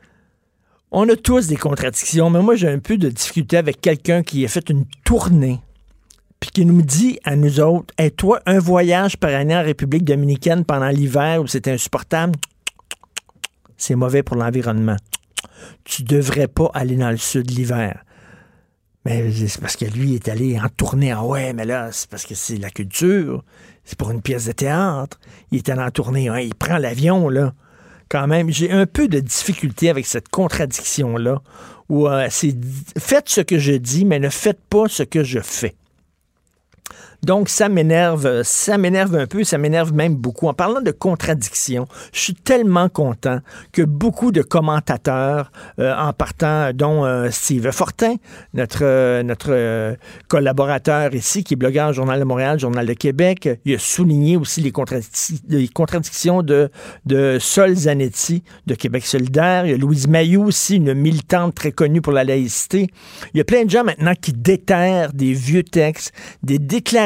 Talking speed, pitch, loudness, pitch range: 185 wpm, 145 Hz, -17 LUFS, 130-175 Hz